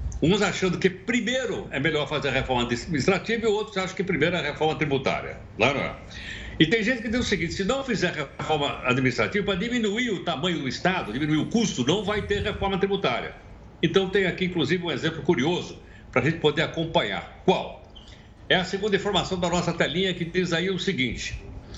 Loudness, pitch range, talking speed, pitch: -25 LUFS, 155-195 Hz, 200 wpm, 180 Hz